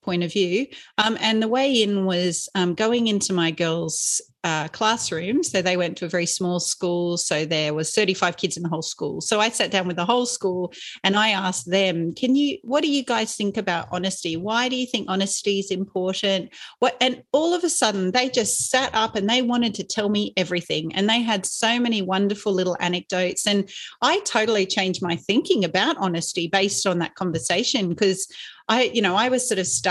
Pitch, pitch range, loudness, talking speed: 195 Hz, 180-225 Hz, -22 LUFS, 215 wpm